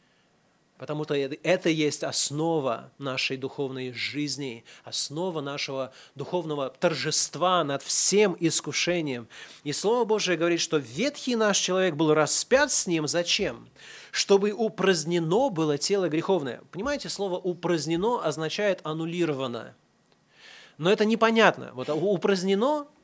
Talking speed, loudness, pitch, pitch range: 110 wpm, -26 LUFS, 165 Hz, 145-195 Hz